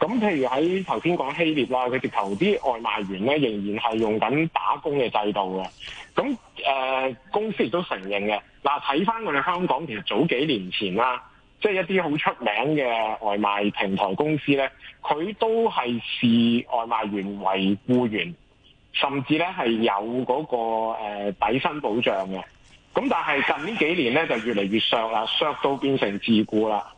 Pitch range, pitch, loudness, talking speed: 100-140 Hz, 115 Hz, -24 LUFS, 250 characters per minute